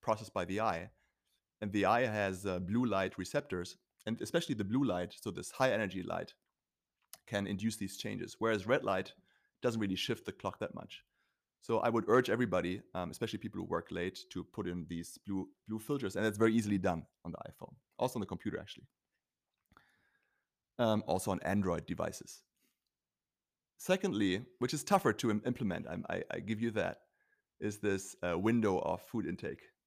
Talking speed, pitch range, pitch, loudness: 185 wpm, 95-115 Hz, 105 Hz, -36 LUFS